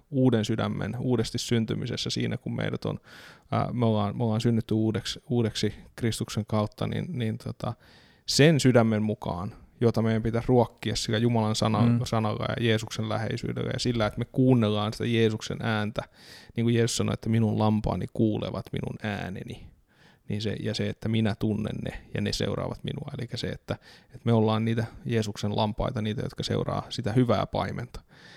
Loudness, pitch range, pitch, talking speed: -27 LUFS, 105-120 Hz, 110 Hz, 165 wpm